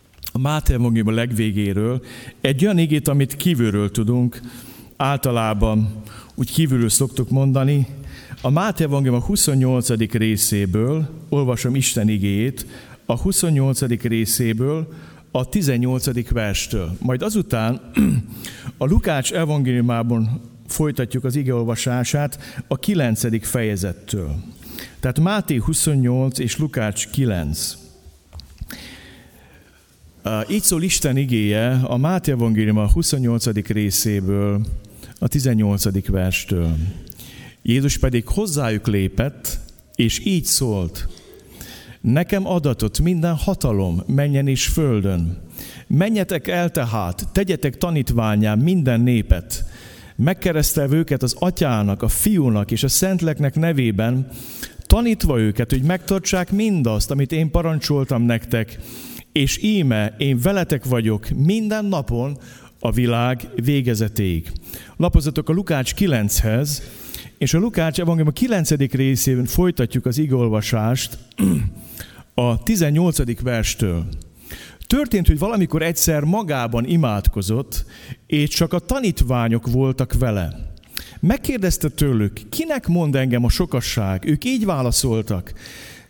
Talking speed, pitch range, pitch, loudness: 105 wpm, 110-150 Hz, 125 Hz, -20 LUFS